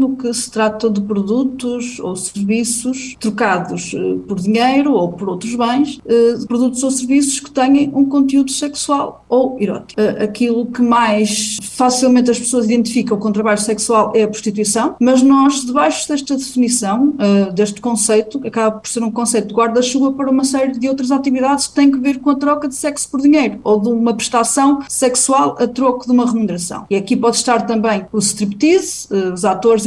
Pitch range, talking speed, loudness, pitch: 215-270 Hz, 180 wpm, -15 LUFS, 240 Hz